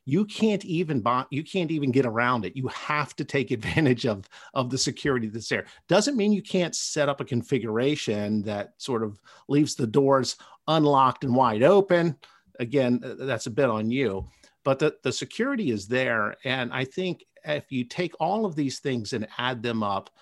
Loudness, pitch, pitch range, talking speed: -26 LUFS, 135 Hz, 120-155 Hz, 195 wpm